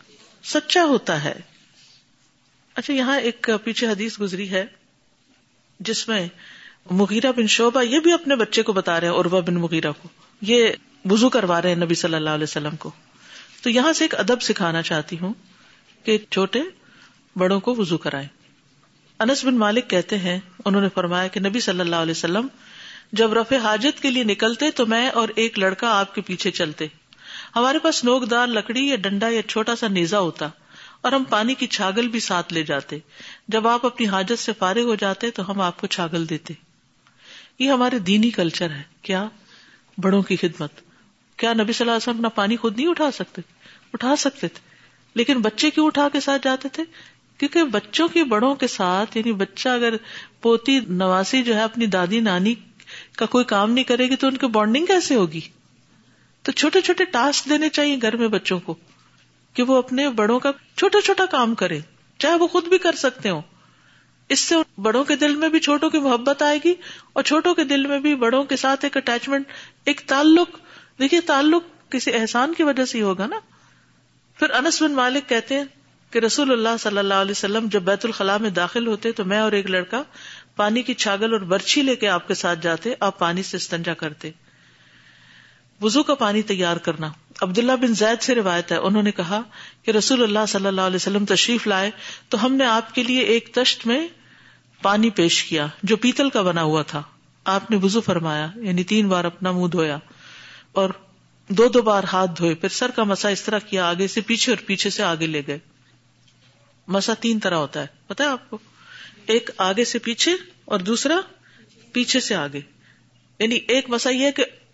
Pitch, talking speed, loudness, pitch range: 220 Hz, 195 wpm, -20 LUFS, 185-255 Hz